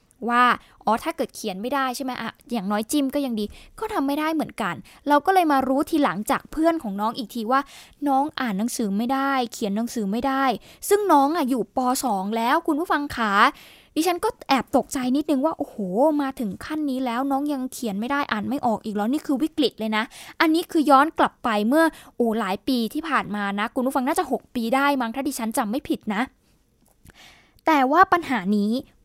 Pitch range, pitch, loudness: 230-295 Hz, 270 Hz, -23 LUFS